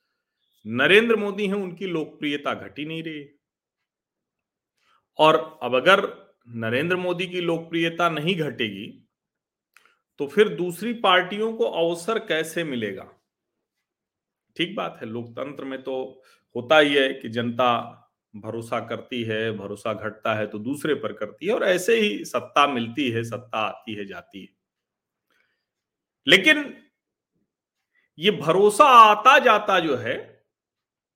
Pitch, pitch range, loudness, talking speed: 155 Hz, 120-185 Hz, -21 LUFS, 125 wpm